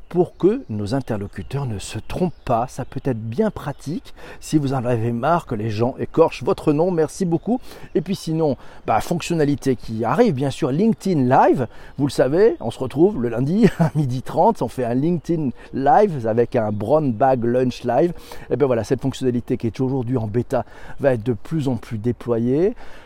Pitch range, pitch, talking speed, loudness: 120-160 Hz, 135 Hz, 200 wpm, -21 LUFS